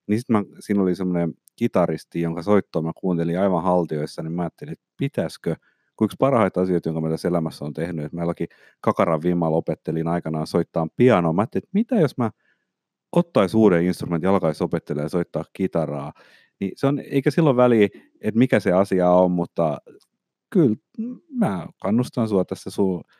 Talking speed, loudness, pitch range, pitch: 175 wpm, -22 LUFS, 85-110 Hz, 90 Hz